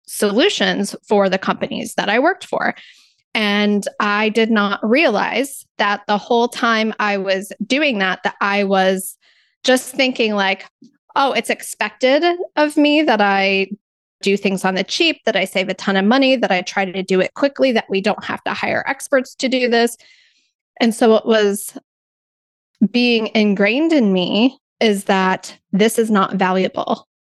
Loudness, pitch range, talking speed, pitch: -17 LUFS, 195-255 Hz, 170 wpm, 215 Hz